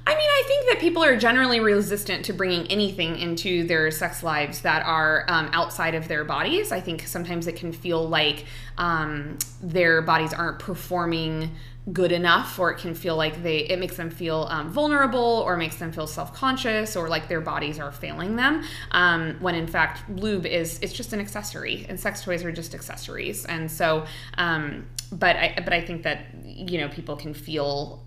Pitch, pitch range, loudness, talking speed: 170 Hz, 155-185 Hz, -24 LUFS, 190 wpm